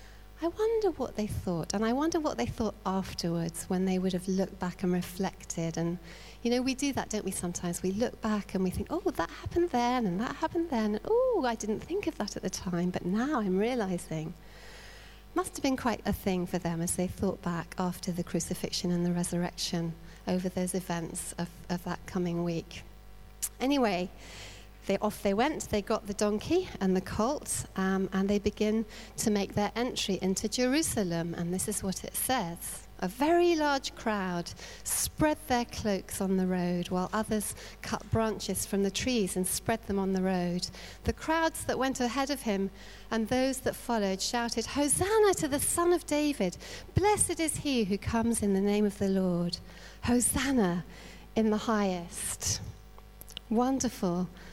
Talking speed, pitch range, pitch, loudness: 185 wpm, 180-245 Hz, 200 Hz, -31 LUFS